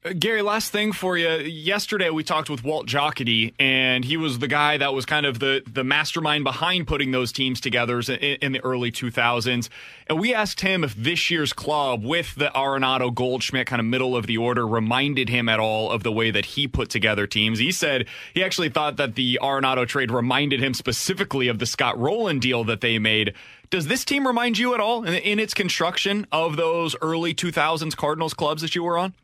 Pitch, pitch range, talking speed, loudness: 140 Hz, 125-165 Hz, 215 wpm, -22 LUFS